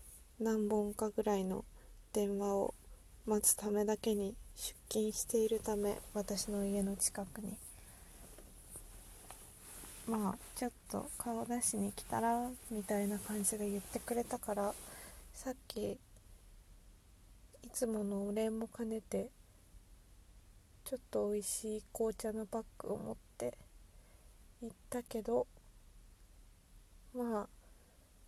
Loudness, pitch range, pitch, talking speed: -39 LUFS, 185-225 Hz, 210 Hz, 210 characters per minute